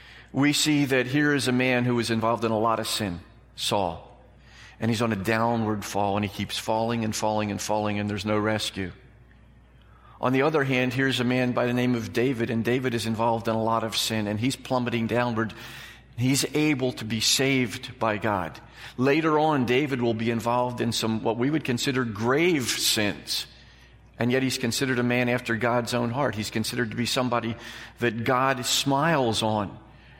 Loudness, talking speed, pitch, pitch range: -25 LUFS, 195 wpm, 120 Hz, 110-125 Hz